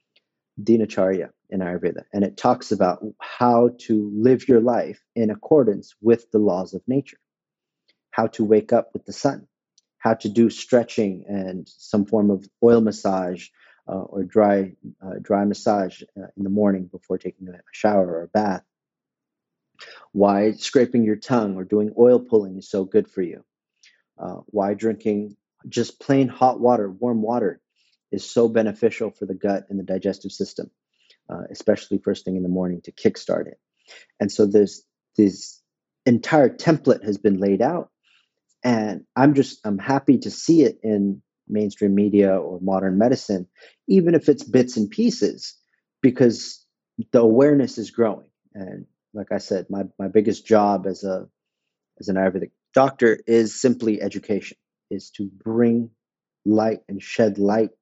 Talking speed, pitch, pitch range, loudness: 160 wpm, 105 Hz, 100-115 Hz, -21 LUFS